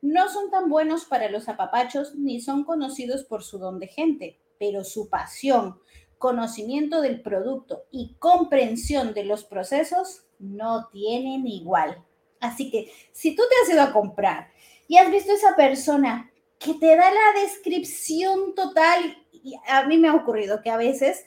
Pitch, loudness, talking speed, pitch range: 270 Hz, -22 LUFS, 165 wpm, 225-325 Hz